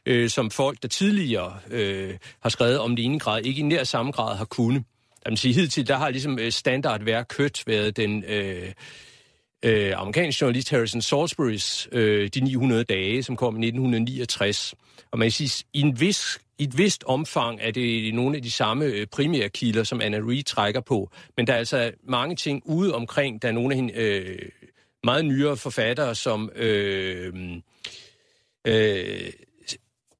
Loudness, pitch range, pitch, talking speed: -24 LUFS, 110-140 Hz, 120 Hz, 175 wpm